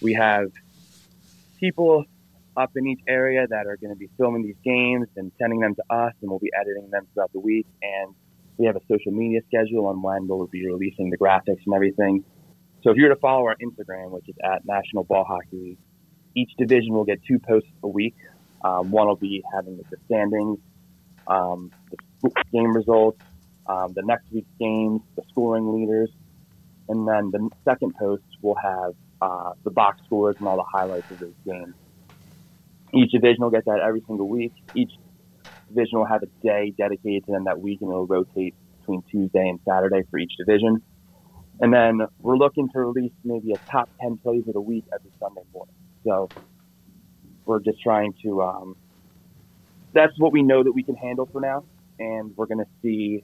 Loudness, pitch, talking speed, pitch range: -23 LUFS, 105 Hz, 190 wpm, 95-115 Hz